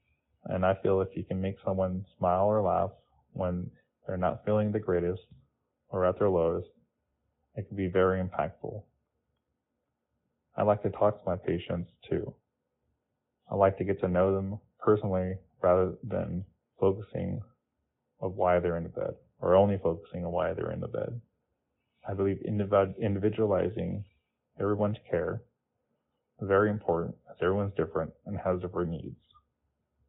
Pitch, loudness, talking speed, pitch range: 95 Hz, -30 LUFS, 150 wpm, 90-105 Hz